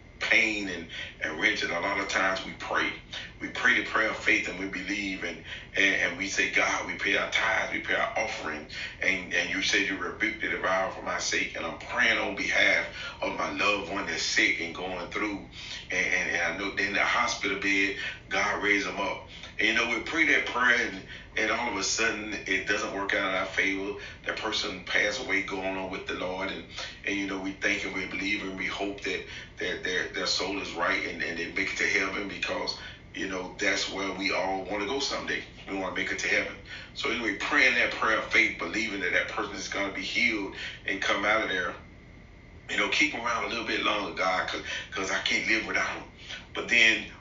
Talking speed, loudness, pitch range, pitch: 235 wpm, -27 LUFS, 95-105 Hz, 100 Hz